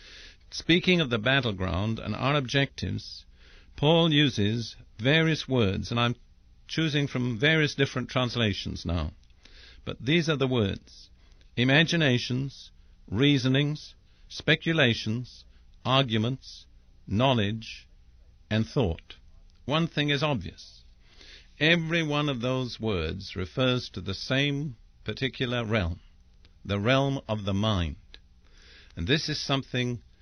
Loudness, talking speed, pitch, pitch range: -27 LUFS, 110 wpm, 115 Hz, 90-140 Hz